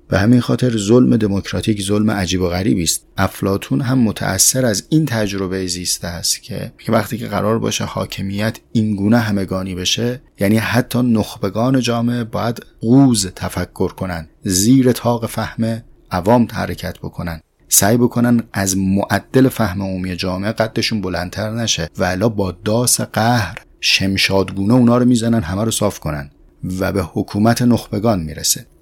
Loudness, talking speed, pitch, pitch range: -17 LUFS, 145 wpm, 105 Hz, 95-120 Hz